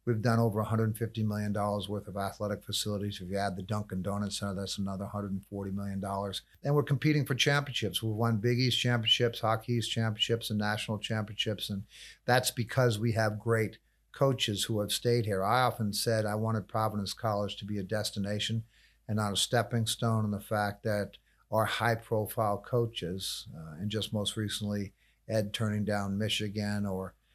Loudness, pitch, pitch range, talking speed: -31 LUFS, 105 Hz, 100-115 Hz, 180 wpm